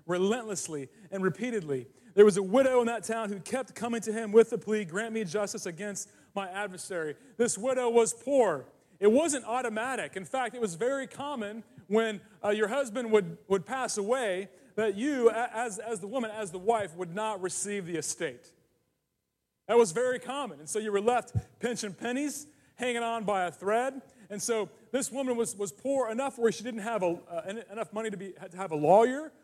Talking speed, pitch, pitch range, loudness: 200 wpm, 220 Hz, 195-240 Hz, -30 LUFS